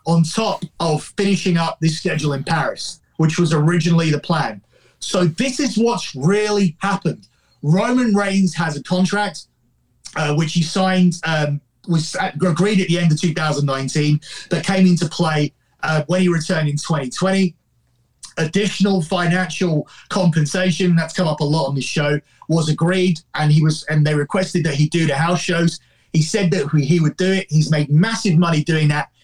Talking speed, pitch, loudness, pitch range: 175 wpm, 165 Hz, -18 LUFS, 155-185 Hz